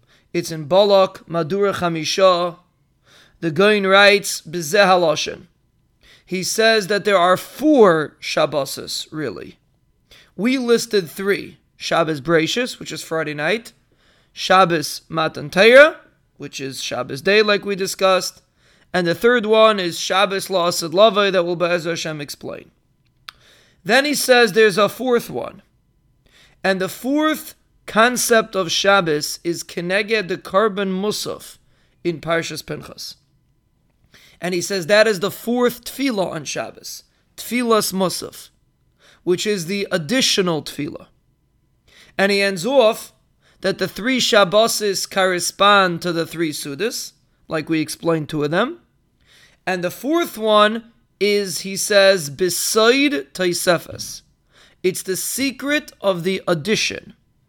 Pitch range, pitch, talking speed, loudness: 170-215 Hz, 190 Hz, 125 wpm, -18 LUFS